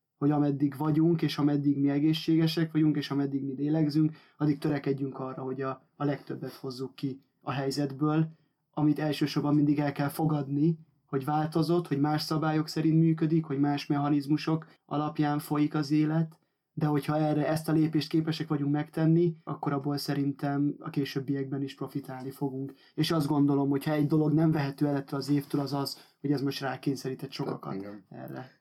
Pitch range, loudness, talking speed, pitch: 140-155 Hz, -29 LUFS, 170 wpm, 145 Hz